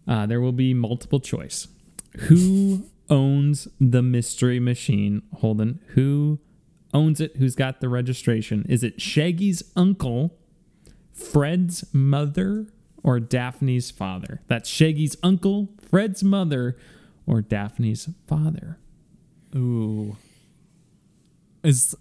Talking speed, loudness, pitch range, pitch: 105 wpm, -22 LUFS, 125-175 Hz, 145 Hz